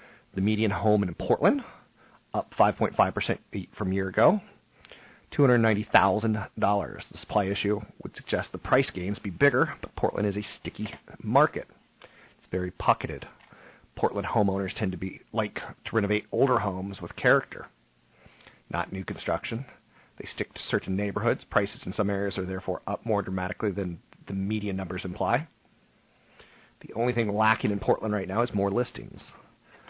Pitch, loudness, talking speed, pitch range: 100 Hz, -28 LUFS, 170 wpm, 95-110 Hz